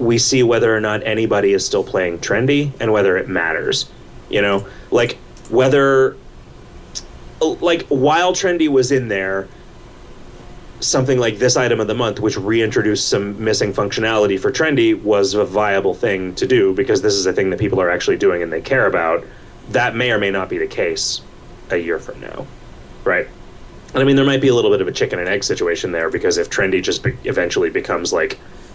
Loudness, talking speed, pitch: -17 LUFS, 200 wpm, 135 Hz